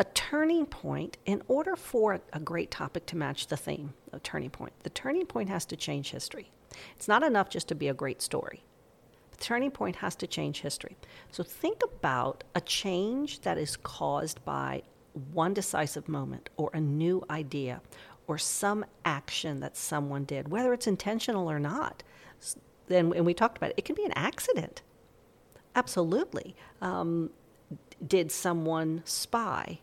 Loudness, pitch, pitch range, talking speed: -32 LUFS, 180 Hz, 155-235 Hz, 165 wpm